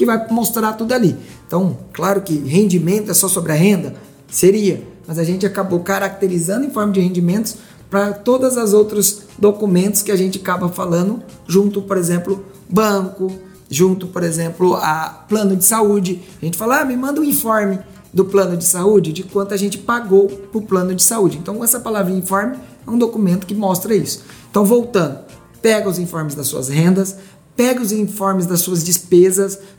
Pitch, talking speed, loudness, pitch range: 195 Hz, 185 wpm, -16 LUFS, 180-210 Hz